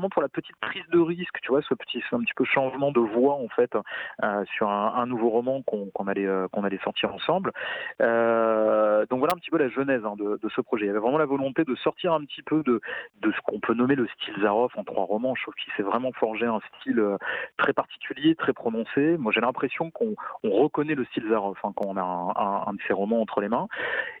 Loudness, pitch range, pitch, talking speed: -26 LUFS, 105-140 Hz, 120 Hz, 255 wpm